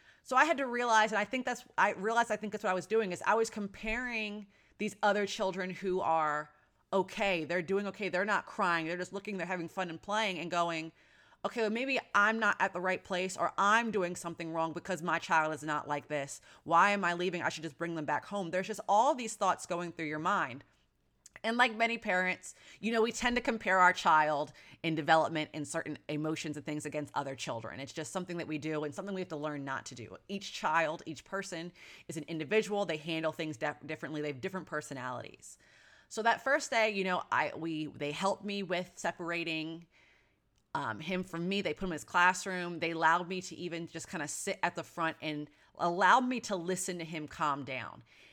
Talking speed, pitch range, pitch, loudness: 225 wpm, 160-200 Hz, 175 Hz, -33 LUFS